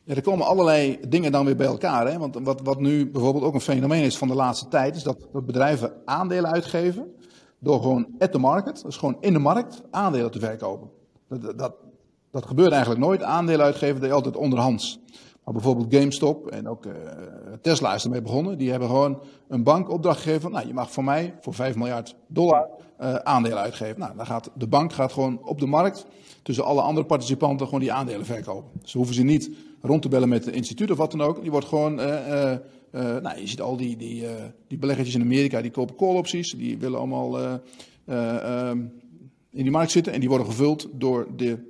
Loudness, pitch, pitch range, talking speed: -24 LUFS, 135 Hz, 120-150 Hz, 215 wpm